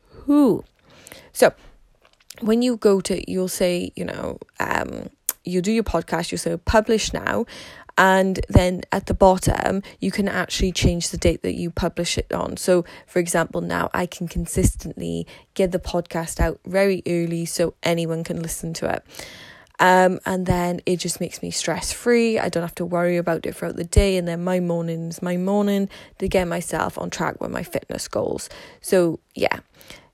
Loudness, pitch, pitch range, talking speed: -22 LUFS, 180 Hz, 170-190 Hz, 180 wpm